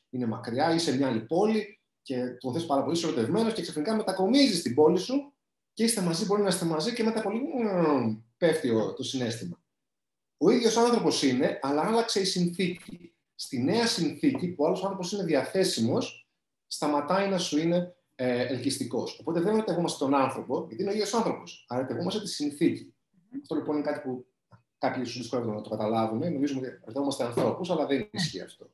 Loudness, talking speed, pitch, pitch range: -28 LUFS, 175 wpm, 165 Hz, 130-205 Hz